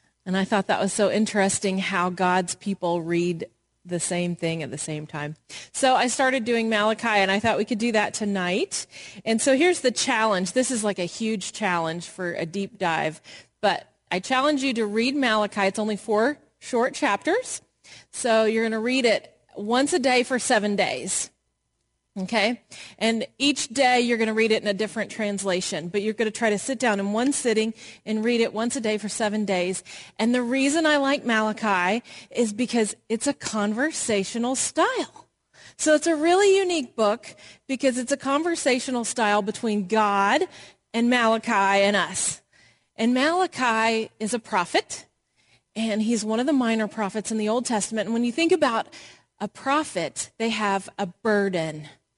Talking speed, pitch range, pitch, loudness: 185 wpm, 200-245 Hz, 220 Hz, -24 LUFS